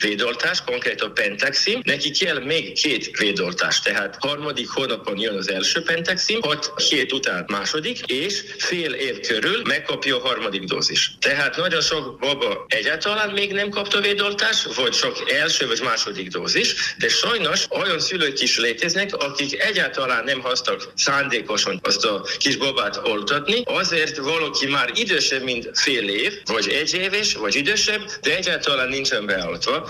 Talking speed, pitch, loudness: 150 wpm, 205 Hz, -20 LUFS